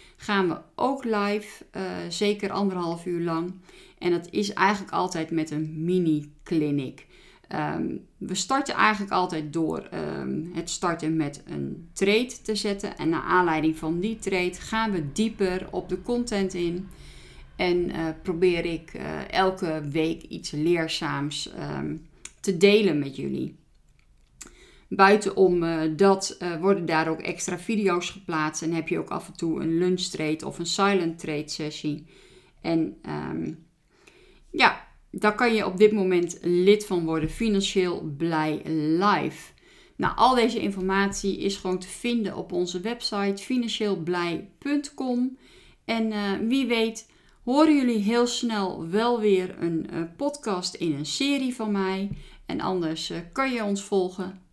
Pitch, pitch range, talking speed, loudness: 185 Hz, 165-205 Hz, 150 wpm, -26 LUFS